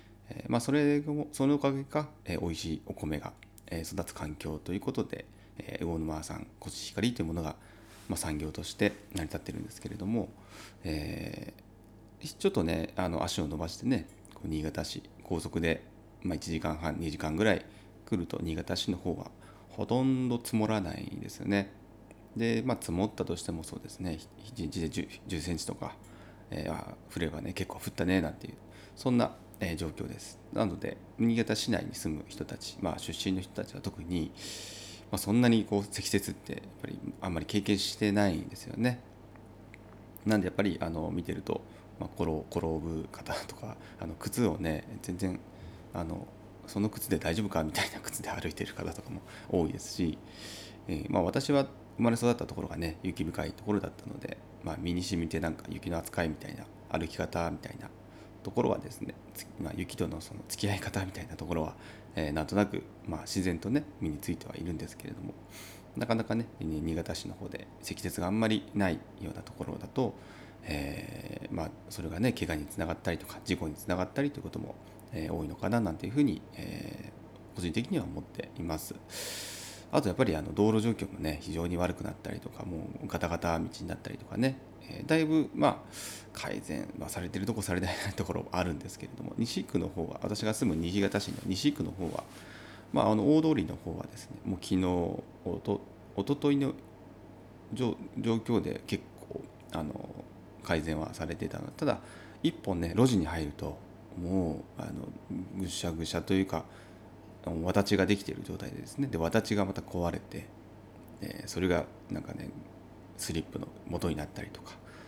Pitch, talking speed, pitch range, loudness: 100 Hz, 350 characters per minute, 85-110 Hz, -34 LUFS